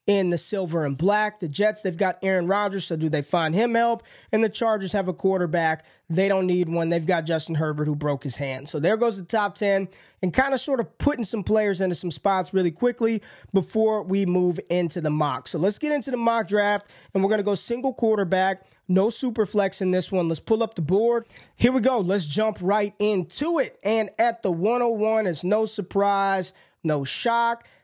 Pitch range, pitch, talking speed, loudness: 180-220 Hz, 195 Hz, 220 wpm, -24 LUFS